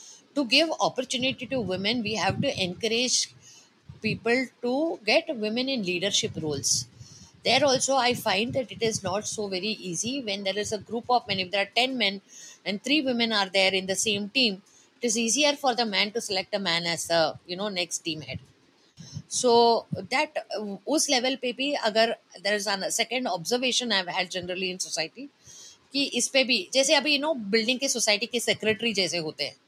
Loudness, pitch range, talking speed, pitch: -25 LUFS, 190-255 Hz, 190 wpm, 220 Hz